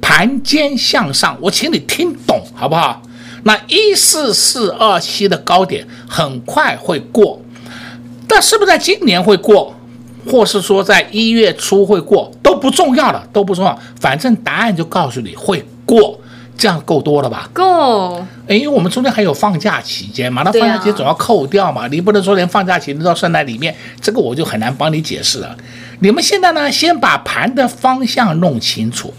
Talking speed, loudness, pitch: 275 characters per minute, -12 LUFS, 200 Hz